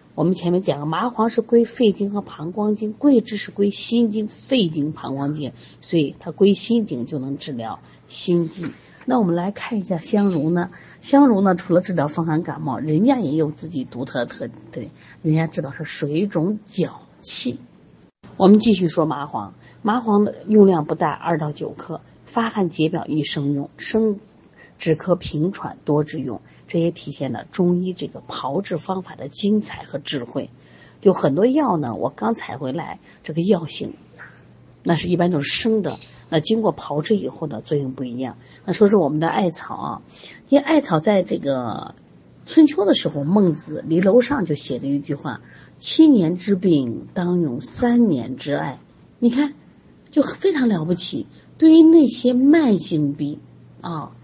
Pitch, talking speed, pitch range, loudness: 175 Hz, 250 characters per minute, 150-215 Hz, -20 LUFS